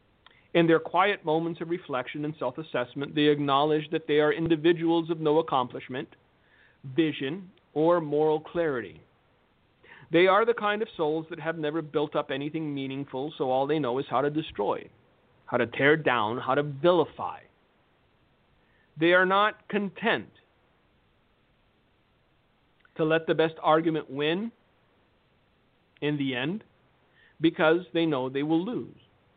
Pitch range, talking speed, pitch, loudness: 145-170 Hz, 140 wpm, 155 Hz, -27 LUFS